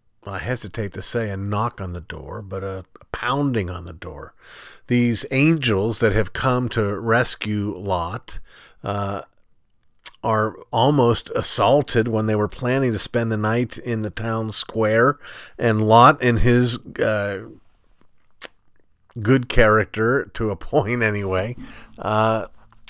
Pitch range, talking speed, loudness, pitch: 100-120 Hz, 135 wpm, -21 LUFS, 110 Hz